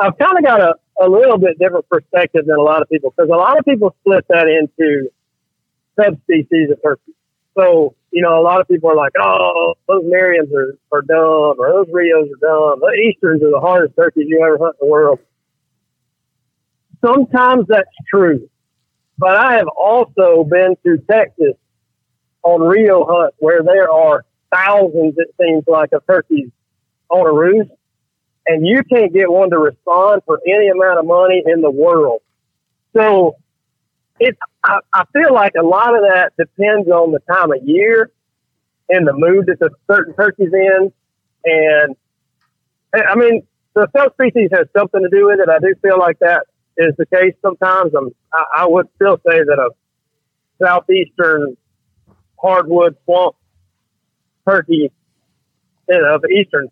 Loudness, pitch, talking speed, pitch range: -12 LUFS, 180 Hz, 170 wpm, 155-205 Hz